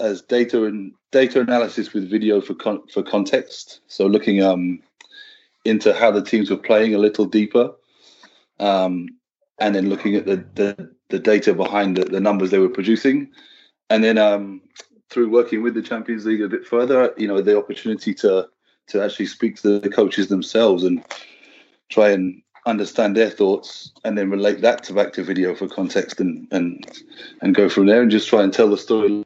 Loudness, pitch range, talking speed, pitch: -19 LUFS, 100-120 Hz, 190 wpm, 105 Hz